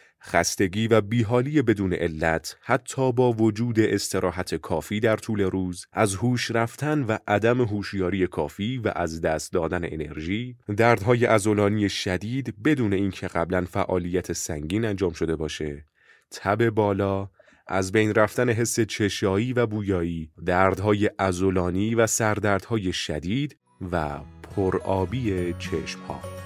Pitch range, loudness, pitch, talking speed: 90-115 Hz, -25 LUFS, 100 Hz, 120 wpm